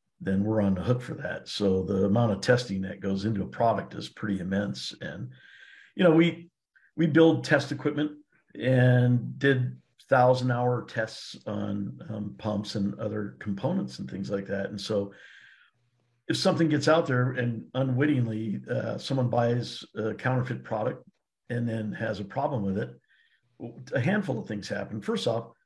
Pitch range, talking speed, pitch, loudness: 100-130 Hz, 170 wpm, 120 Hz, -28 LUFS